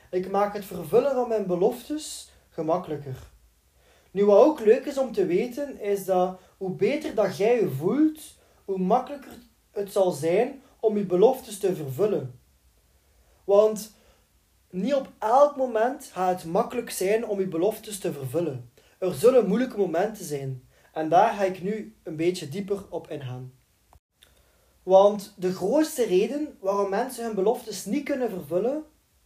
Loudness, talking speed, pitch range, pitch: -25 LUFS, 150 wpm, 165-240 Hz, 200 Hz